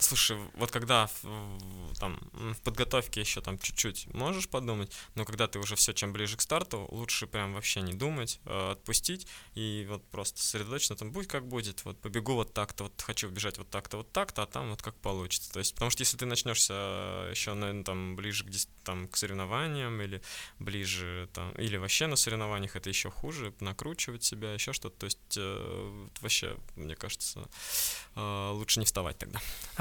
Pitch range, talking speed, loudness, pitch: 100-115 Hz, 180 wpm, -33 LUFS, 105 Hz